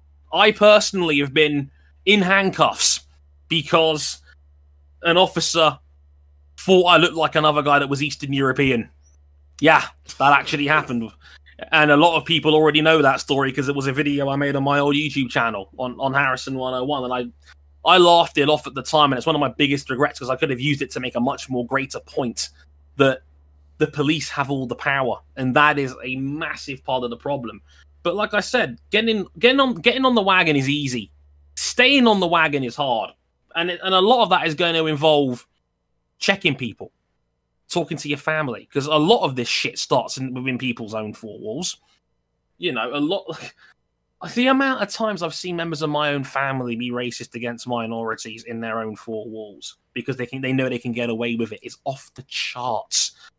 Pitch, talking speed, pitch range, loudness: 140 Hz, 205 wpm, 115-155 Hz, -19 LUFS